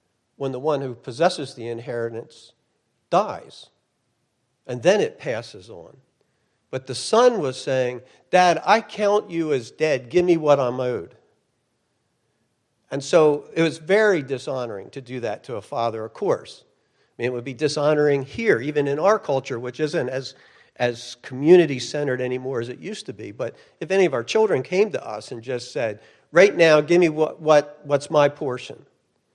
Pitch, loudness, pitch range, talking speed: 145 Hz, -21 LUFS, 125-165 Hz, 175 wpm